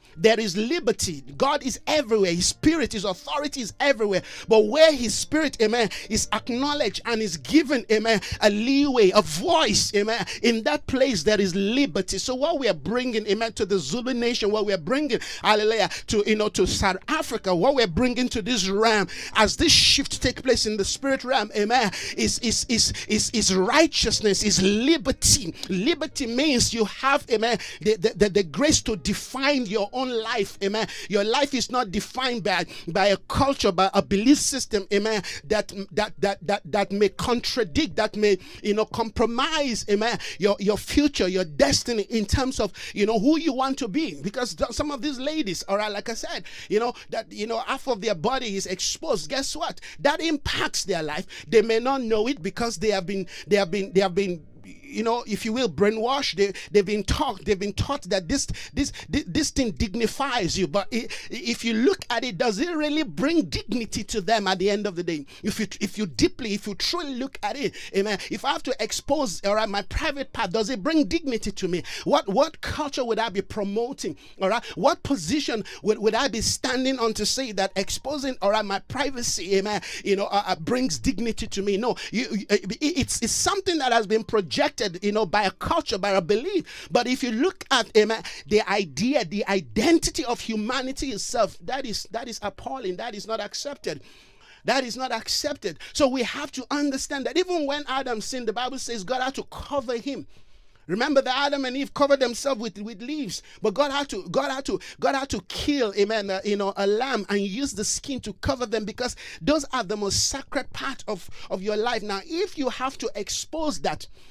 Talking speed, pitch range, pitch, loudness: 205 wpm, 205-270 Hz, 225 Hz, -24 LUFS